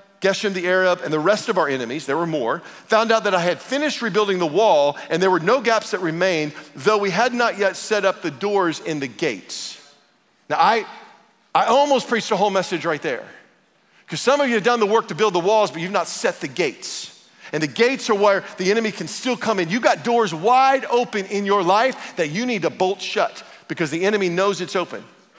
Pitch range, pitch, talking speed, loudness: 185-235 Hz, 205 Hz, 235 wpm, -20 LUFS